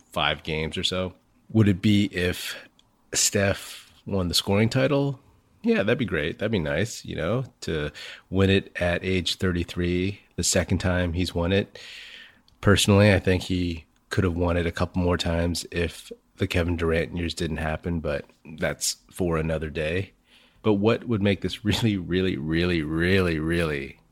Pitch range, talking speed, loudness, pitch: 85-100 Hz, 170 wpm, -25 LUFS, 90 Hz